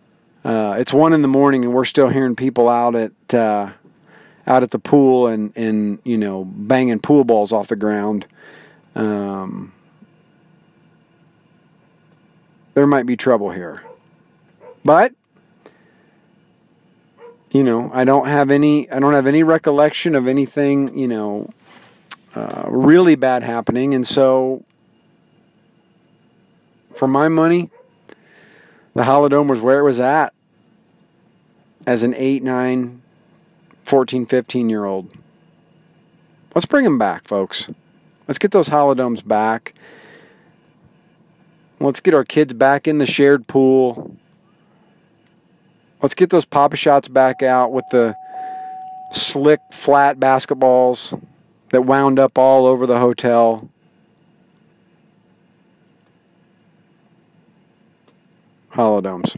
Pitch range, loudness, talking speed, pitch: 125-170 Hz, -15 LUFS, 115 wpm, 140 Hz